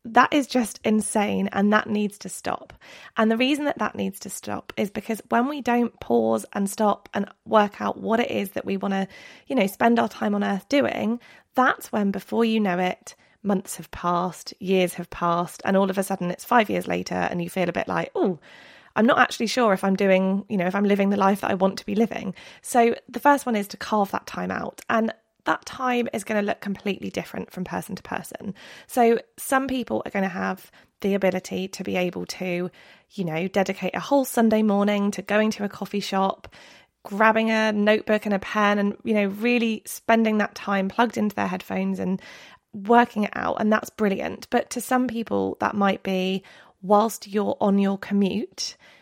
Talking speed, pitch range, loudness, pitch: 215 wpm, 190-225 Hz, -24 LUFS, 205 Hz